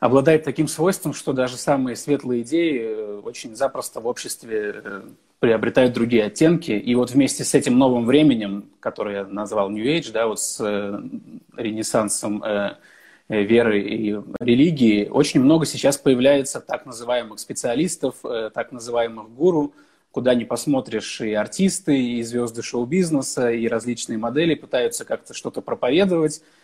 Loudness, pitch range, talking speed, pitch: -21 LUFS, 115-155 Hz, 135 wpm, 125 Hz